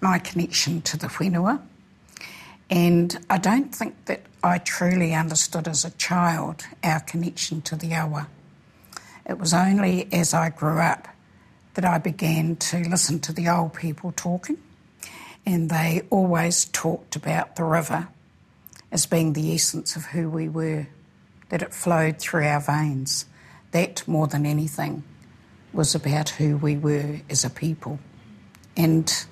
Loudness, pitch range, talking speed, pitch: -23 LUFS, 155-175 Hz, 145 wpm, 165 Hz